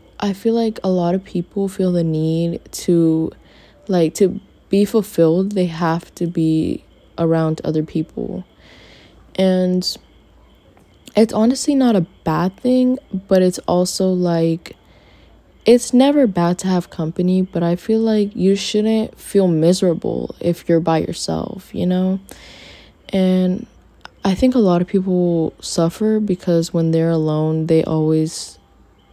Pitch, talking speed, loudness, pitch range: 180 Hz, 140 wpm, -18 LUFS, 165-200 Hz